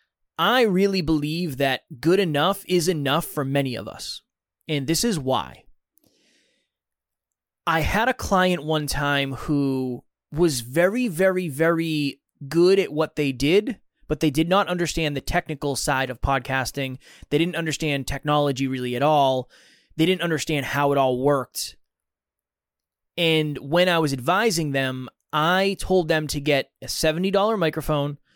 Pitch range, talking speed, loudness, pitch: 135-175 Hz, 150 wpm, -23 LUFS, 150 Hz